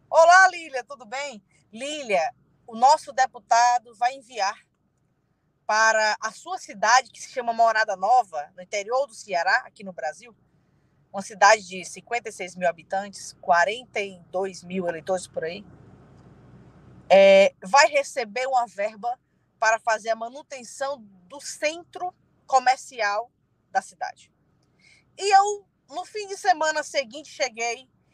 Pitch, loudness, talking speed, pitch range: 235 Hz, -23 LUFS, 125 wpm, 195-285 Hz